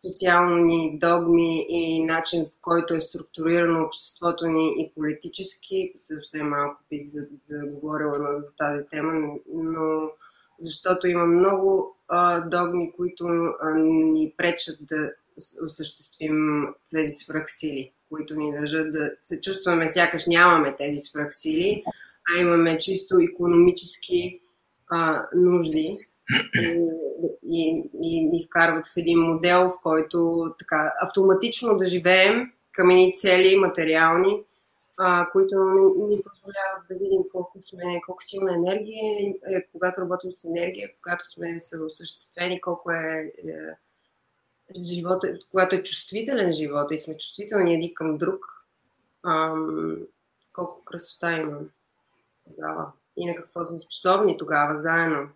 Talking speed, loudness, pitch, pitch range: 125 wpm, -23 LUFS, 170 Hz, 155-185 Hz